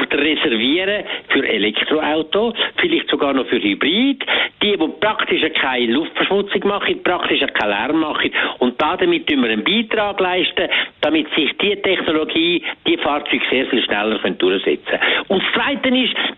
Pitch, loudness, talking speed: 235 Hz, -17 LUFS, 150 wpm